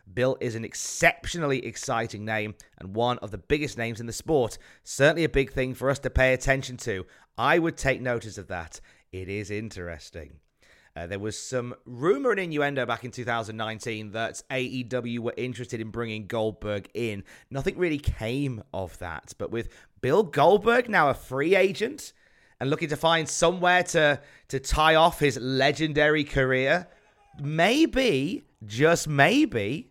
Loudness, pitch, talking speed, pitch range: -26 LUFS, 125 Hz, 160 wpm, 110-150 Hz